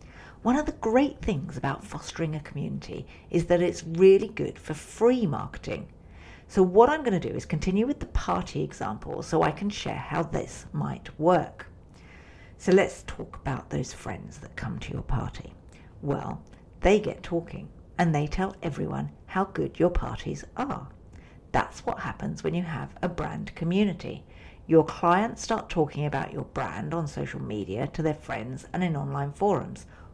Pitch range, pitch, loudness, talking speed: 140-190 Hz, 165 Hz, -28 LUFS, 175 wpm